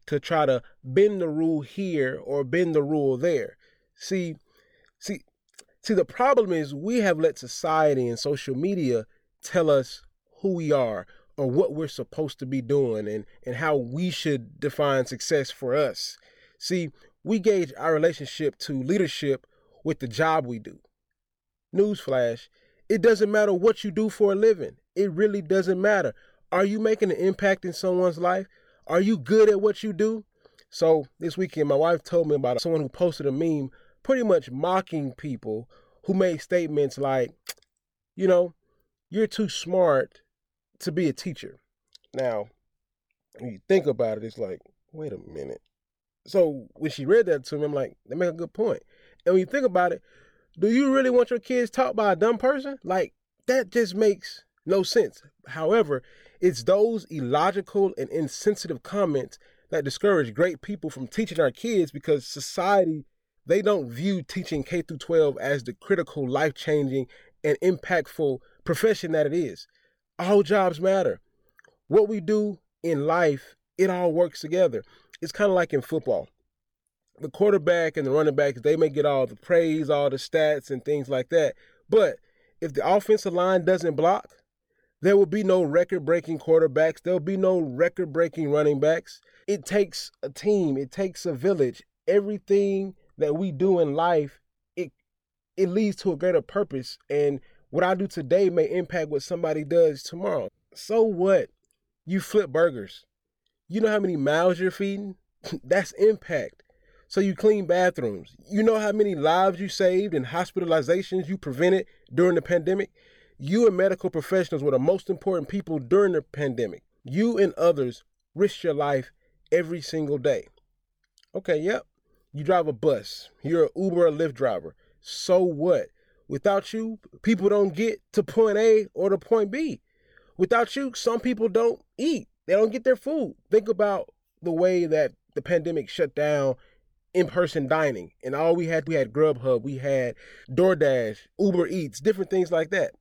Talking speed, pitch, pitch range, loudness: 170 wpm, 180 Hz, 155-210 Hz, -24 LUFS